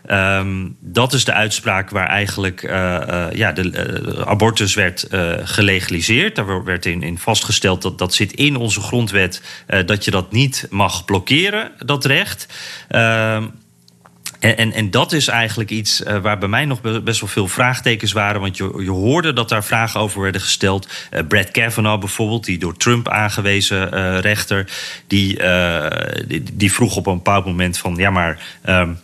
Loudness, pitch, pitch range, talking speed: -16 LUFS, 100 Hz, 95-115 Hz, 180 wpm